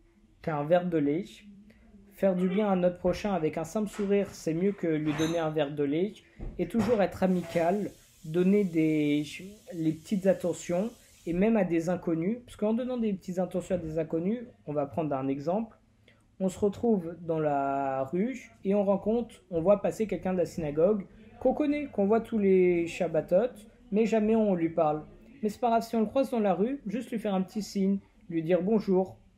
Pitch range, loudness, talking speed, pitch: 165-215 Hz, -29 LUFS, 200 wpm, 185 Hz